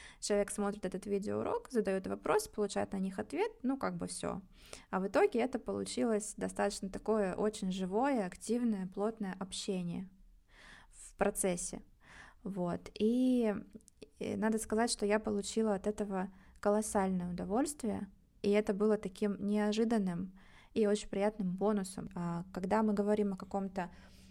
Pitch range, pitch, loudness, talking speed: 190-215 Hz, 205 Hz, -35 LUFS, 135 wpm